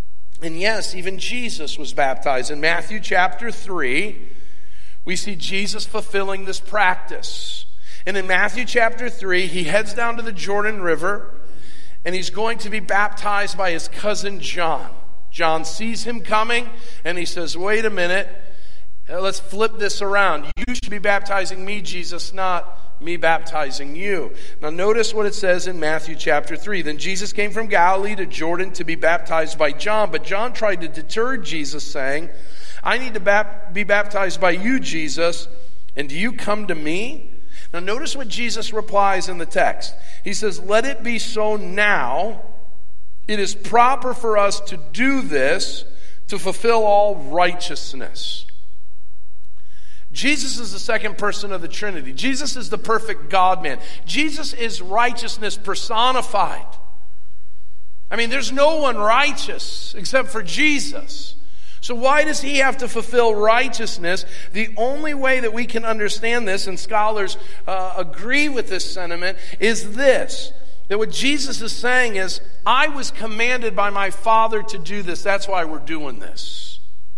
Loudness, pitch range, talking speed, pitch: -21 LUFS, 175-225 Hz, 155 wpm, 200 Hz